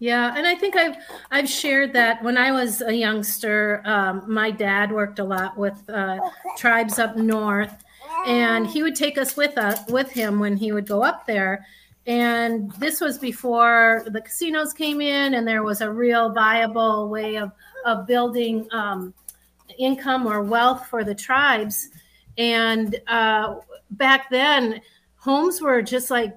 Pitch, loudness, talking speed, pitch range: 230 Hz, -21 LUFS, 165 wpm, 215-260 Hz